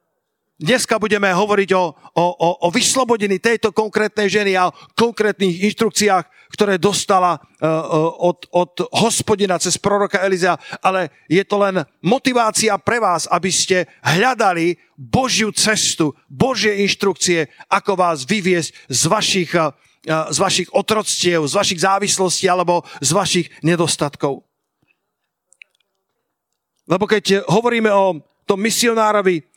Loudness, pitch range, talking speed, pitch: -17 LUFS, 170-210 Hz, 115 wpm, 190 Hz